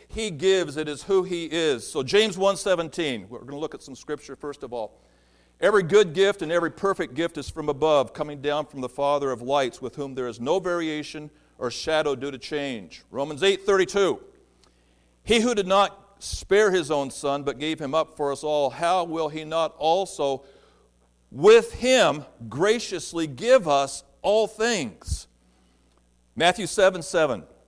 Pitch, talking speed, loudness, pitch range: 155 Hz, 180 wpm, -24 LUFS, 140-195 Hz